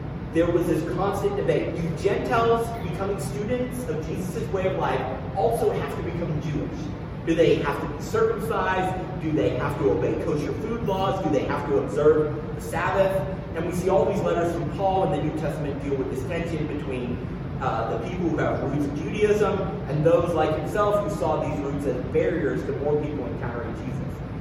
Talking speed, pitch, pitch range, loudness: 195 wpm, 155 Hz, 145-175 Hz, -25 LUFS